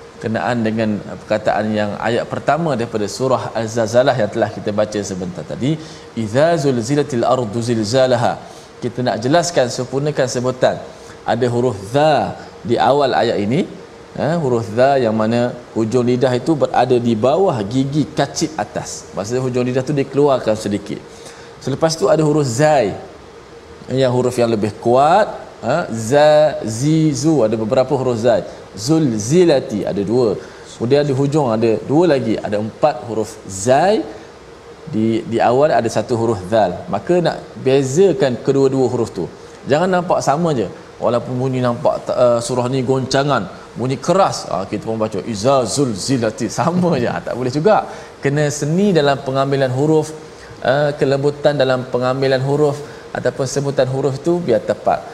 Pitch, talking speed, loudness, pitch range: 125 Hz, 150 wpm, -17 LUFS, 115-145 Hz